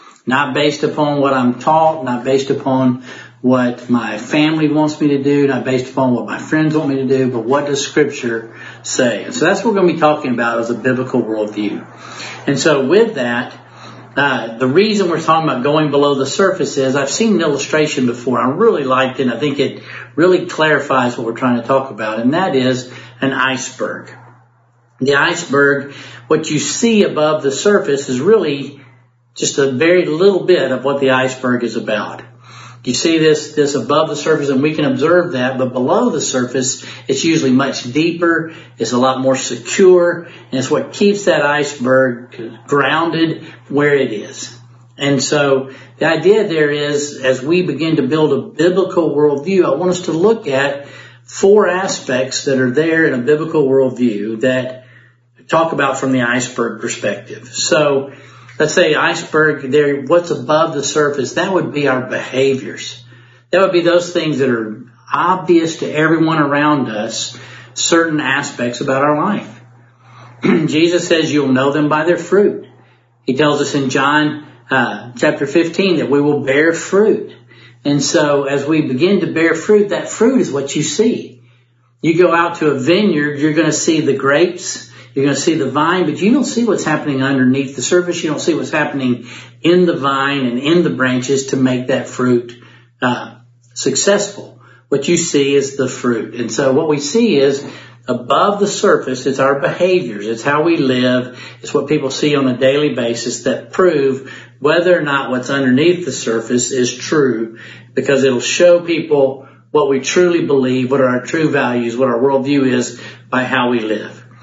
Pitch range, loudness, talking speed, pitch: 125-155 Hz, -14 LUFS, 185 wpm, 140 Hz